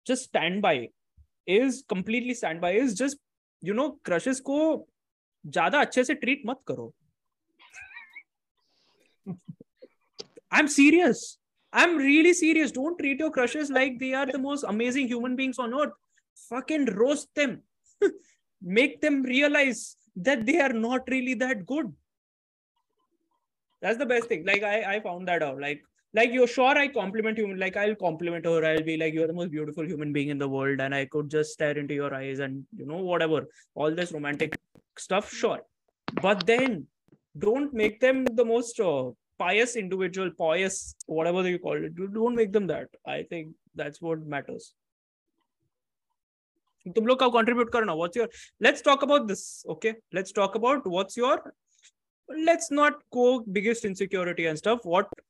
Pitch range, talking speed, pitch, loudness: 175-280 Hz, 150 wpm, 235 Hz, -26 LUFS